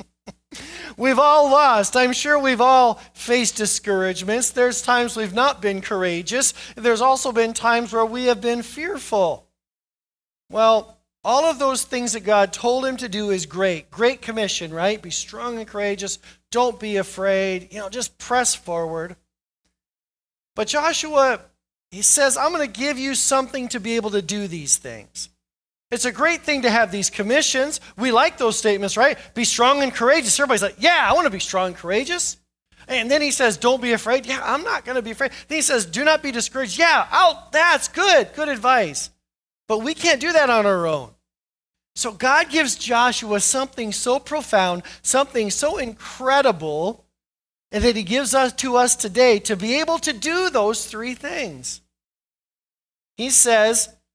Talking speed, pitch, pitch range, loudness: 175 wpm, 240 Hz, 205-270 Hz, -19 LUFS